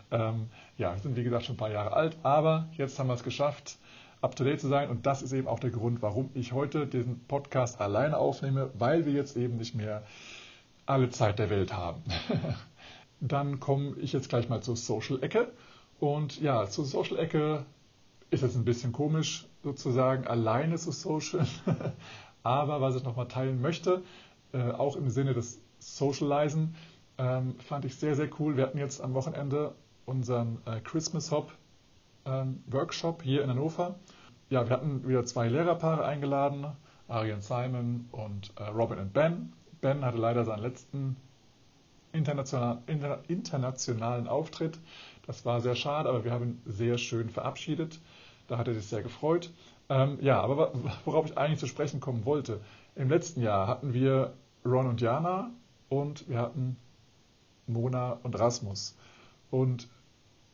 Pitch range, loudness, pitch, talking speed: 120-145 Hz, -31 LUFS, 130 Hz, 155 wpm